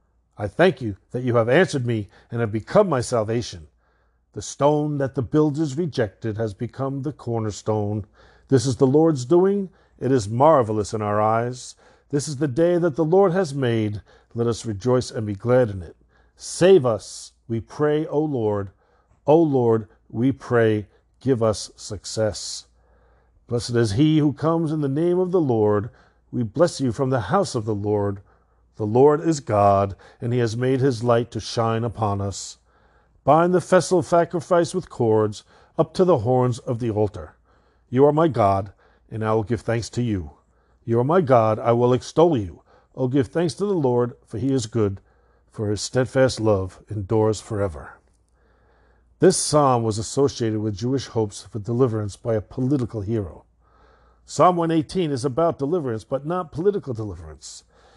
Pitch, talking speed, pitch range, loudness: 120 Hz, 175 wpm, 110-150 Hz, -22 LUFS